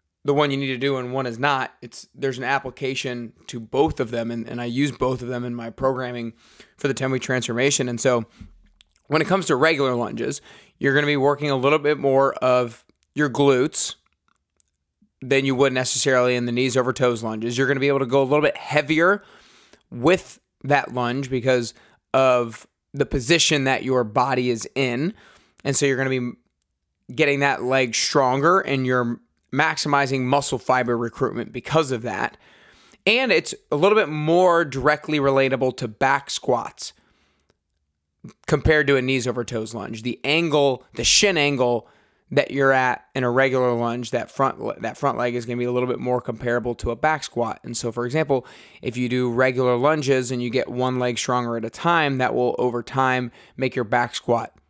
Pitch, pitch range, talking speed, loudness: 130 Hz, 120-140 Hz, 190 wpm, -21 LUFS